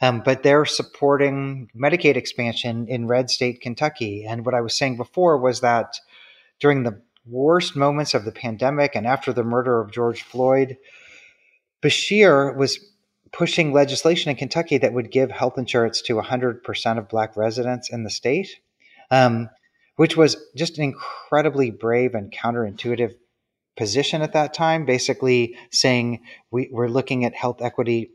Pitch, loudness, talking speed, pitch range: 125 Hz, -21 LUFS, 155 wpm, 120-145 Hz